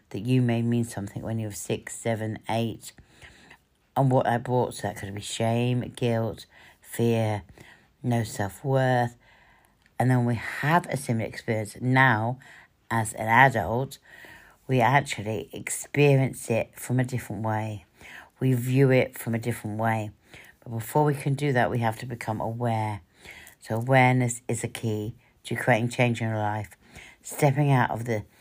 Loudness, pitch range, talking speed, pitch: -26 LUFS, 110-125 Hz, 165 wpm, 115 Hz